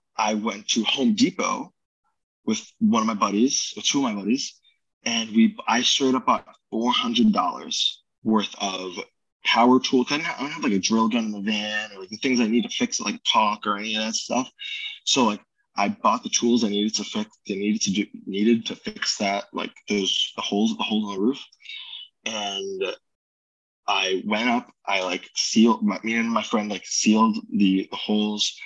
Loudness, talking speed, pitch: -23 LUFS, 205 wpm, 120 Hz